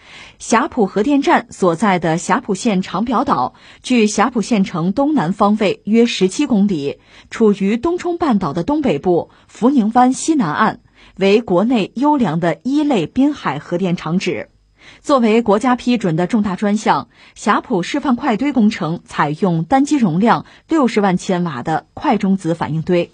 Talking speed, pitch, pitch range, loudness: 245 characters per minute, 210 Hz, 185-255 Hz, -16 LUFS